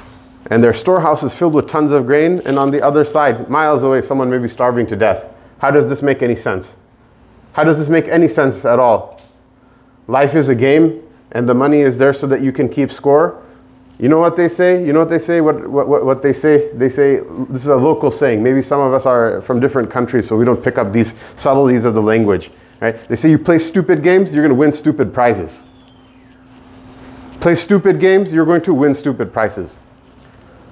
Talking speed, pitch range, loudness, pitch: 220 wpm, 125-150 Hz, -13 LUFS, 135 Hz